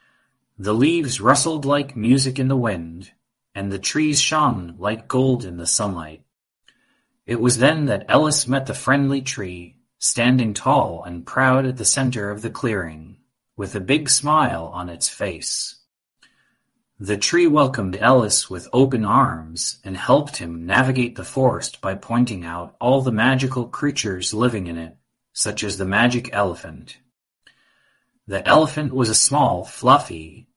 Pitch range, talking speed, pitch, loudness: 95-130 Hz, 150 wpm, 120 Hz, -19 LUFS